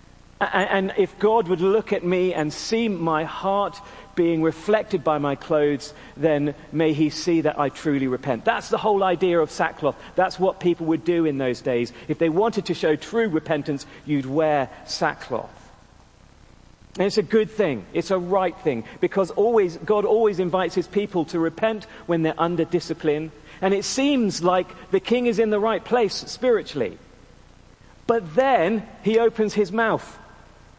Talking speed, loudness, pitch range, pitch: 170 wpm, -23 LUFS, 155-210 Hz, 180 Hz